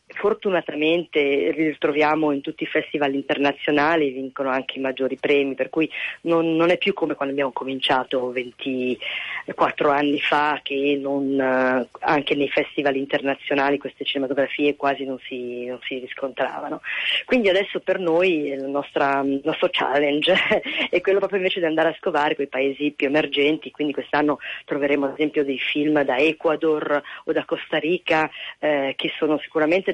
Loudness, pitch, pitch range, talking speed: -22 LUFS, 145 Hz, 135-160 Hz, 160 wpm